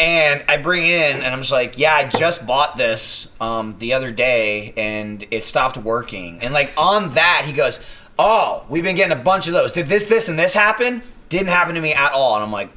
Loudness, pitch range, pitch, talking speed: -17 LUFS, 115-175 Hz, 140 Hz, 240 wpm